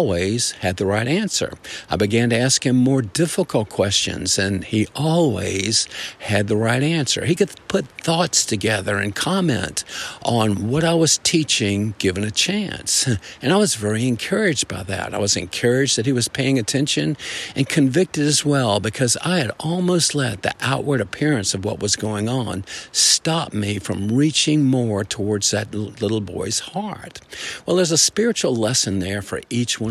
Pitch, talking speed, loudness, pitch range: 120 Hz, 175 wpm, -19 LUFS, 105-150 Hz